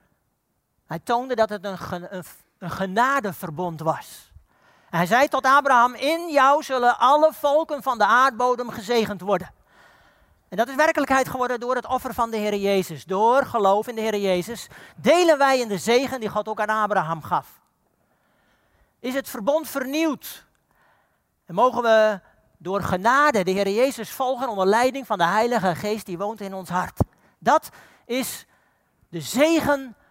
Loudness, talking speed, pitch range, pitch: -22 LUFS, 160 wpm, 195-265 Hz, 235 Hz